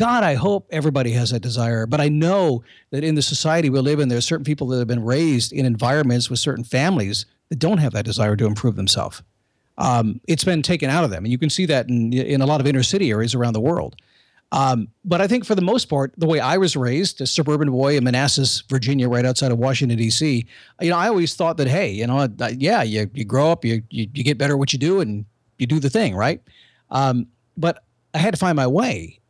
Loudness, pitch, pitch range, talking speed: -20 LUFS, 135 Hz, 120-155 Hz, 250 wpm